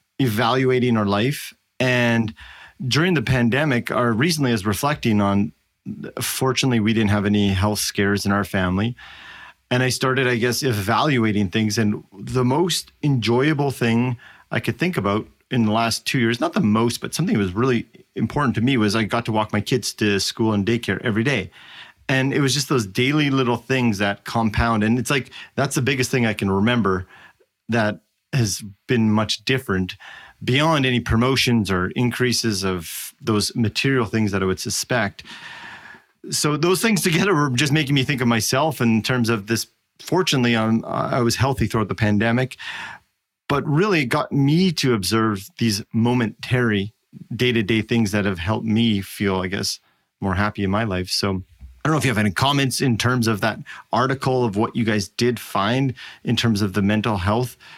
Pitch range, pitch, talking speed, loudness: 105-130 Hz, 115 Hz, 185 wpm, -20 LUFS